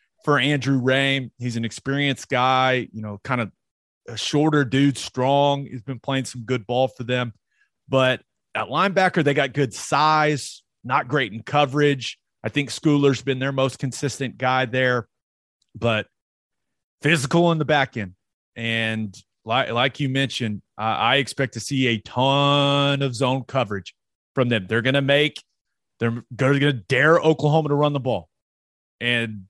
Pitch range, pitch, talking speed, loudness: 115-140 Hz, 130 Hz, 160 wpm, -21 LUFS